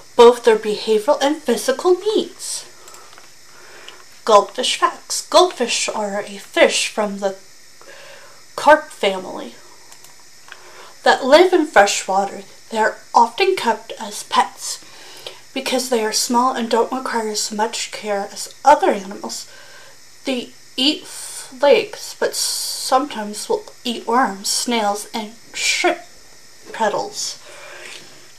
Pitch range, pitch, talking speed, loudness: 215-355 Hz, 255 Hz, 110 wpm, -18 LUFS